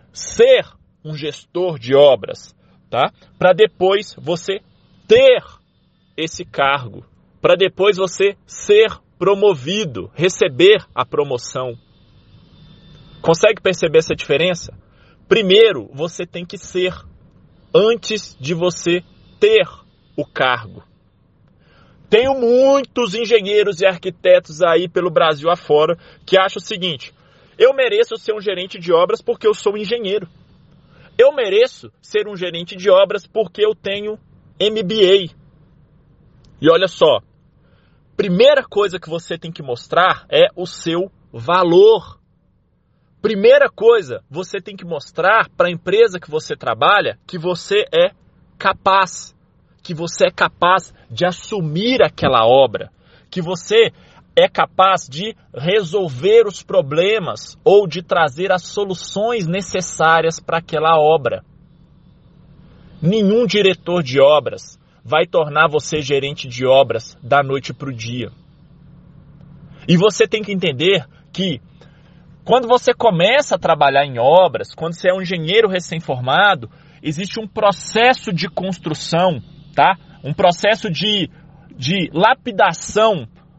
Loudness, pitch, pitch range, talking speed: -16 LUFS, 180 Hz, 160-215 Hz, 120 wpm